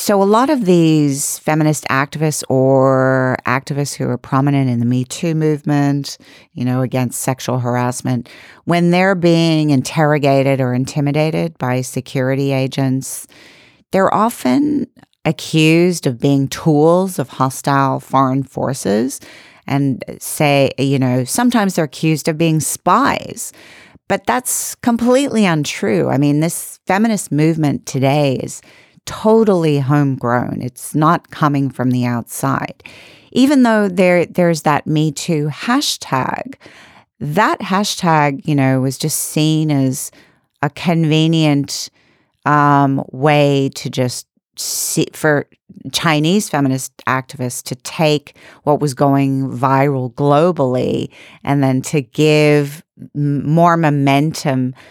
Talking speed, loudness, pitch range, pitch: 120 wpm, -15 LUFS, 135-165 Hz, 145 Hz